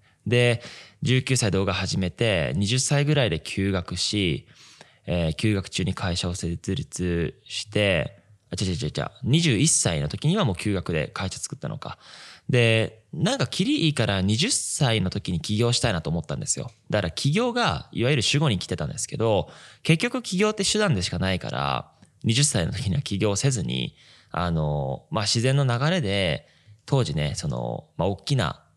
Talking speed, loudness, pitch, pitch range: 295 characters per minute, -24 LUFS, 110 Hz, 95-140 Hz